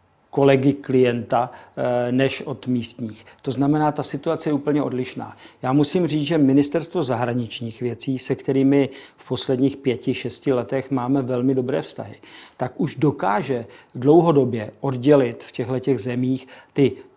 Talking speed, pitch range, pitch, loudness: 135 wpm, 125-140 Hz, 135 Hz, -21 LUFS